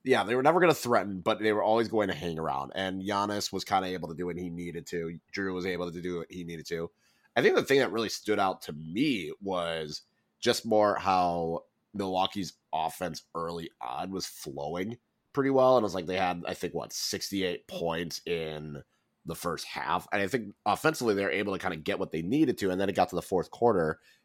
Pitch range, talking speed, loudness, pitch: 85-105 Hz, 235 wpm, -30 LUFS, 90 Hz